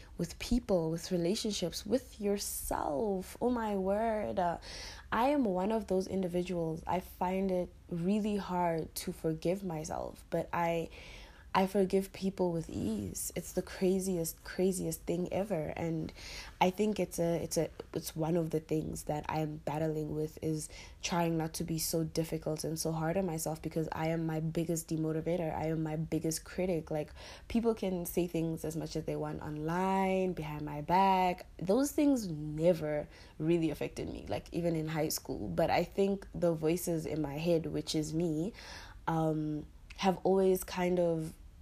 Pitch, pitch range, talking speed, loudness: 170 Hz, 160-185 Hz, 170 wpm, -34 LUFS